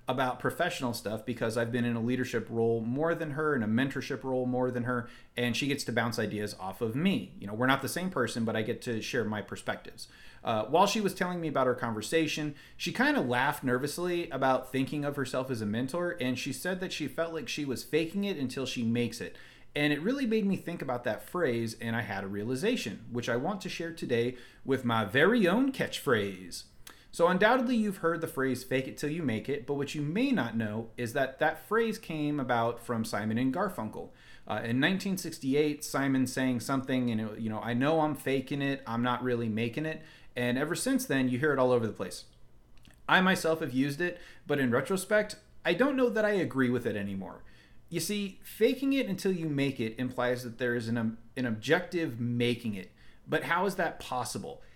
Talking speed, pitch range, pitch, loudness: 220 wpm, 120-165 Hz, 130 Hz, -31 LUFS